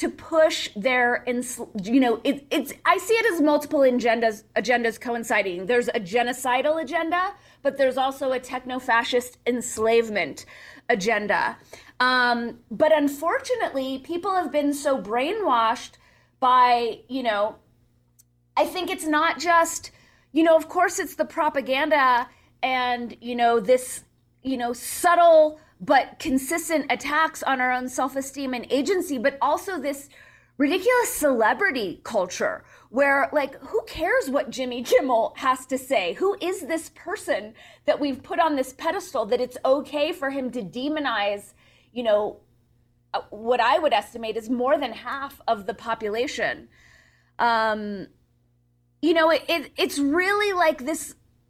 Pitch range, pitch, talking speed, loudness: 235-315 Hz, 265 Hz, 140 wpm, -23 LUFS